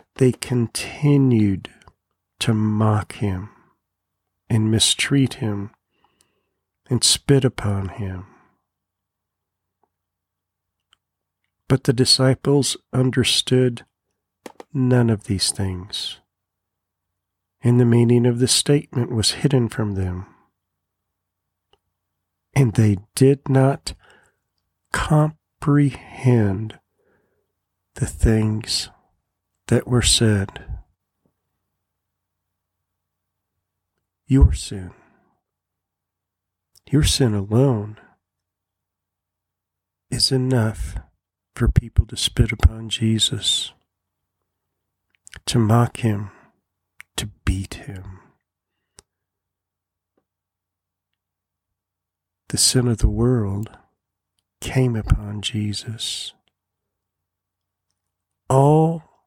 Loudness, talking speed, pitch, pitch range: -20 LUFS, 70 wpm, 100 Hz, 95-120 Hz